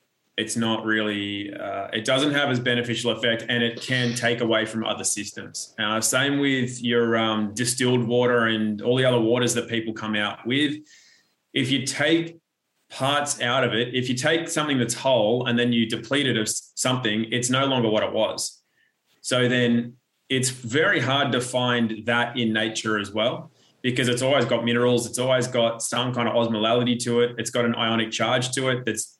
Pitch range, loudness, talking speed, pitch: 115-130 Hz, -23 LUFS, 195 wpm, 120 Hz